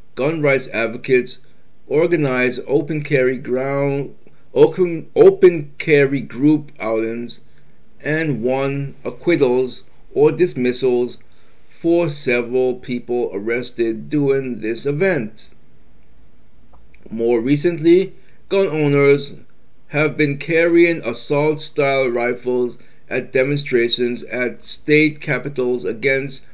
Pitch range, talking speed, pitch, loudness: 125-155 Hz, 90 wpm, 135 Hz, -18 LUFS